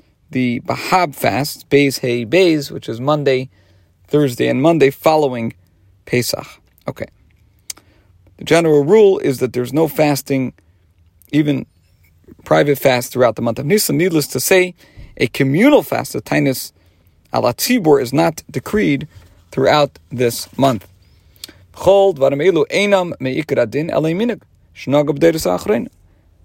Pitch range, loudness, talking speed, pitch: 95-150 Hz, -16 LUFS, 115 wpm, 130 Hz